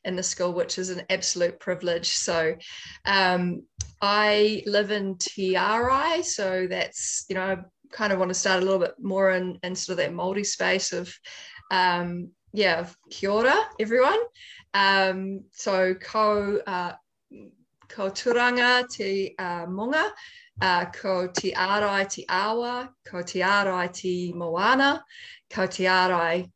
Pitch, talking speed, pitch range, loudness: 190 Hz, 140 wpm, 180-210 Hz, -25 LUFS